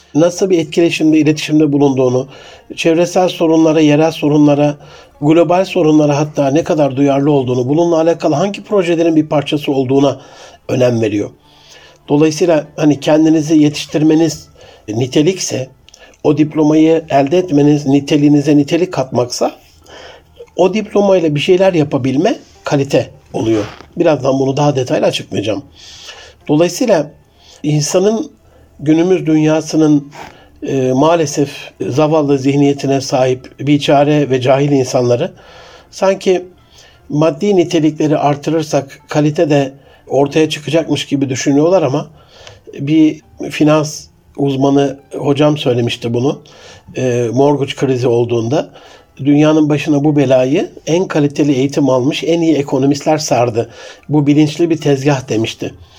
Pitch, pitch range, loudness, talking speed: 150 Hz, 140-160 Hz, -13 LUFS, 110 wpm